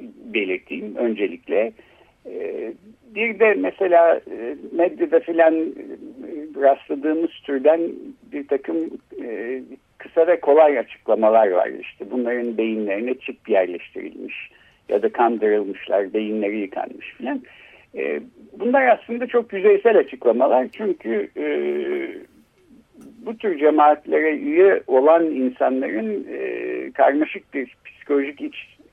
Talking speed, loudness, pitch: 90 wpm, -20 LUFS, 205 Hz